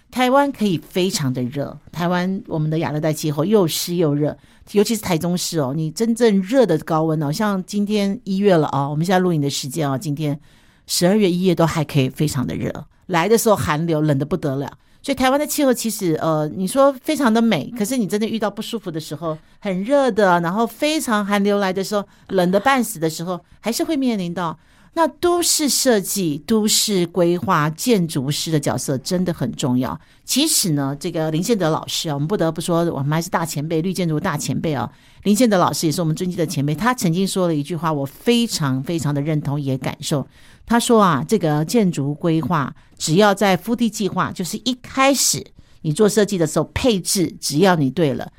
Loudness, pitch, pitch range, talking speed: -19 LUFS, 175 Hz, 155-215 Hz, 315 characters per minute